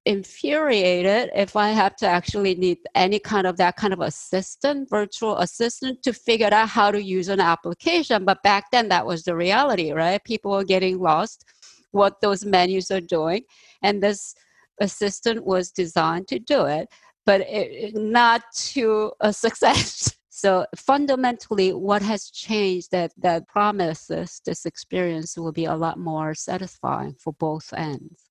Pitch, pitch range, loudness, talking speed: 195 Hz, 175-215 Hz, -22 LUFS, 155 wpm